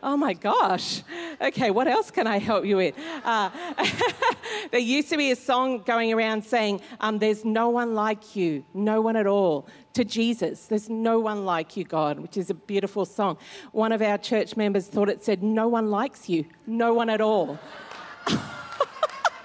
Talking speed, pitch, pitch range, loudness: 185 wpm, 220 Hz, 200-240 Hz, -25 LUFS